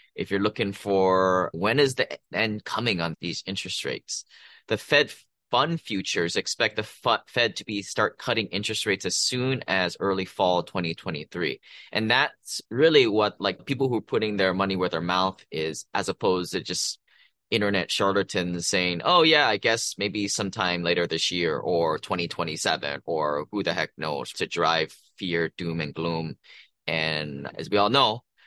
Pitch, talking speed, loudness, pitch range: 95 Hz, 175 wpm, -25 LUFS, 85-105 Hz